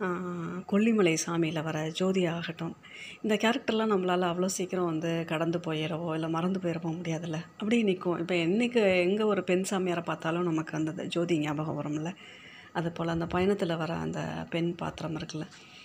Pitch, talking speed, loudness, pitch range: 170 Hz, 150 wpm, -30 LUFS, 160-185 Hz